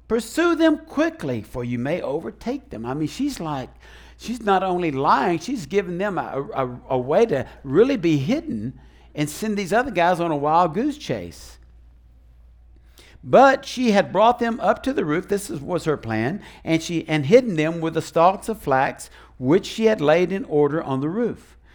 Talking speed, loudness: 195 wpm, -21 LUFS